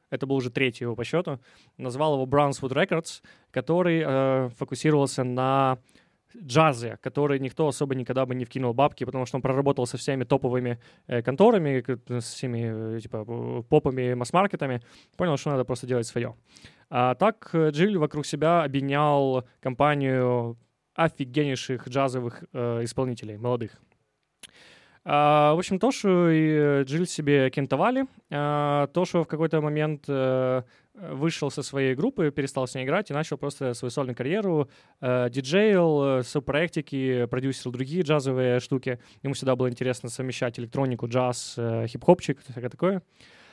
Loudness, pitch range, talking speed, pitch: -26 LUFS, 125-150 Hz, 140 wpm, 135 Hz